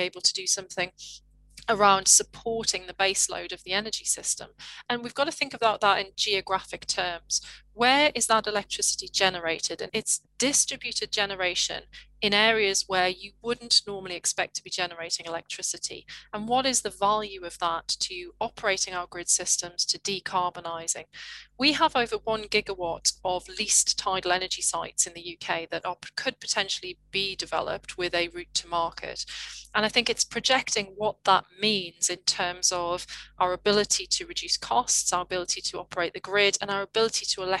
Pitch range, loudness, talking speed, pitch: 180-225 Hz, -26 LUFS, 170 wpm, 195 Hz